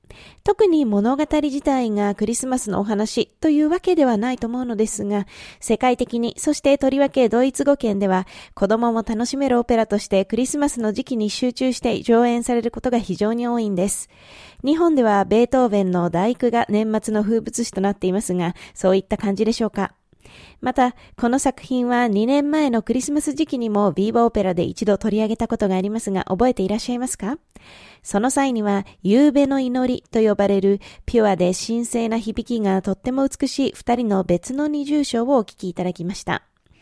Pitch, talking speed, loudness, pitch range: 230 Hz, 385 characters per minute, -20 LUFS, 205-255 Hz